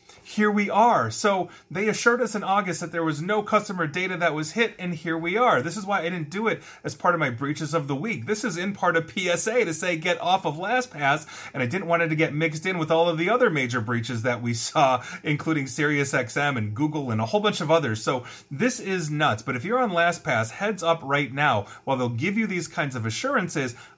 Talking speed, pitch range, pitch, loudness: 250 wpm, 145-190 Hz, 165 Hz, -24 LUFS